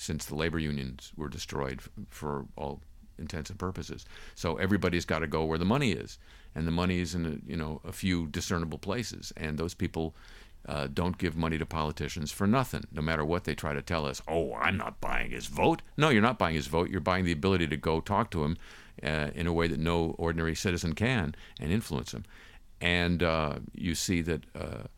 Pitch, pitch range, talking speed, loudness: 85 Hz, 75-90 Hz, 215 wpm, -31 LUFS